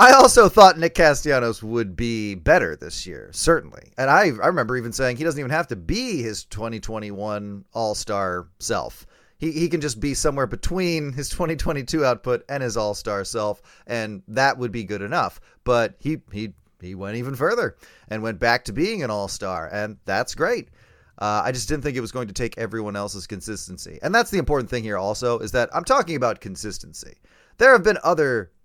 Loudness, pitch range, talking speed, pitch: -21 LUFS, 105-145 Hz, 205 wpm, 115 Hz